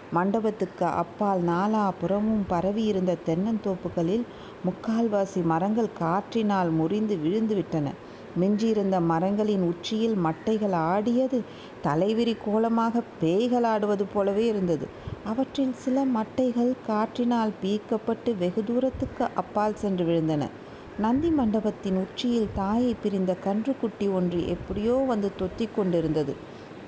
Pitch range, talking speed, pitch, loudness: 185-225 Hz, 95 wpm, 210 Hz, -26 LUFS